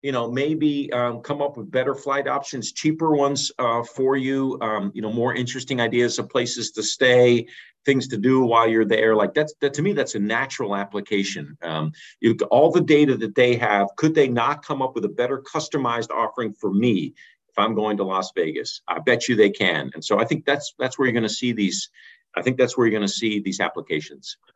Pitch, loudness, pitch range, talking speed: 120 Hz, -22 LUFS, 110-140 Hz, 230 wpm